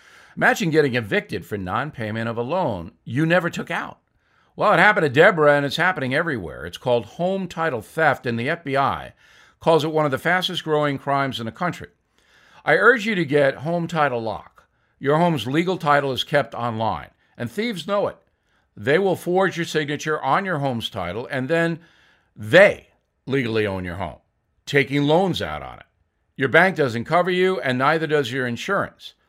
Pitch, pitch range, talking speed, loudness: 145 Hz, 120-165 Hz, 185 wpm, -21 LUFS